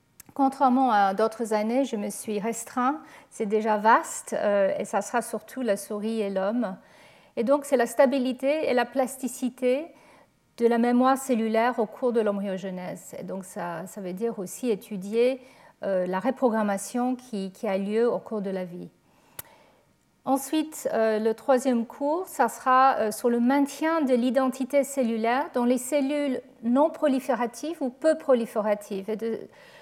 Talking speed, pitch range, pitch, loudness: 155 wpm, 215-270 Hz, 245 Hz, -26 LUFS